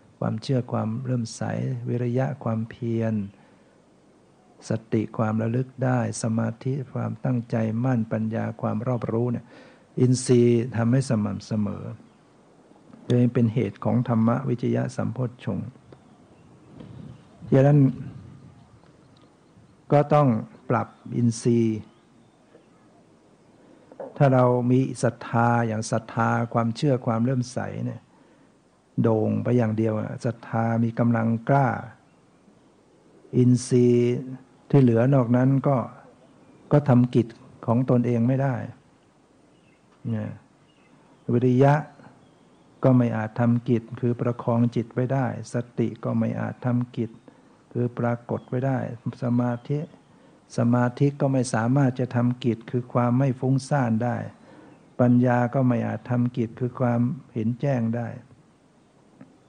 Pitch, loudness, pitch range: 120 Hz, -24 LUFS, 115-130 Hz